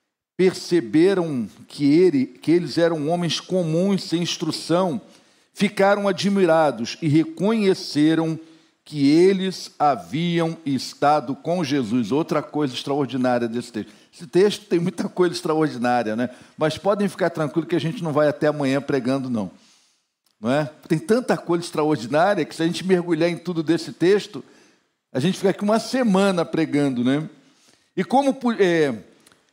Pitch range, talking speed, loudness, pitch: 150-190 Hz, 145 wpm, -21 LUFS, 165 Hz